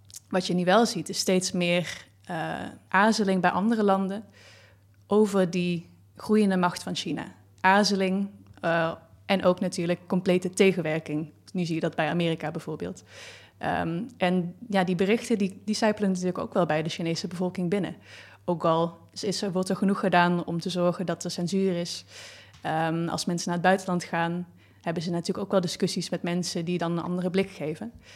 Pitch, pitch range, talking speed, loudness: 180 Hz, 165-190 Hz, 180 wpm, -27 LUFS